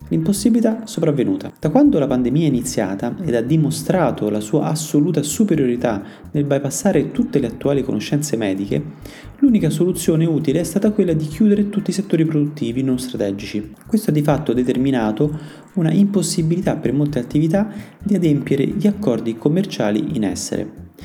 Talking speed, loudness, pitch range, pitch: 150 wpm, -18 LUFS, 125-190 Hz, 150 Hz